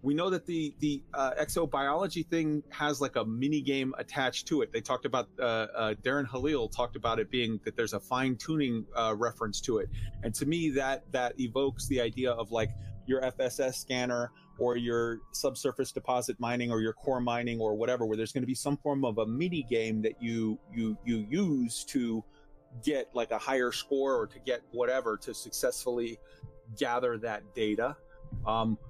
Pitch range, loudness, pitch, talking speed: 115-140 Hz, -32 LUFS, 125 Hz, 190 wpm